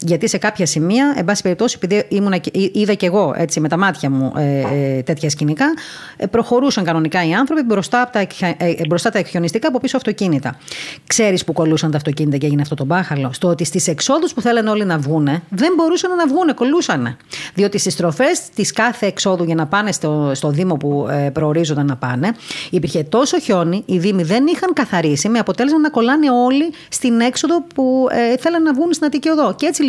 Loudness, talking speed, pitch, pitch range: -16 LUFS, 195 wpm, 195 Hz, 160-245 Hz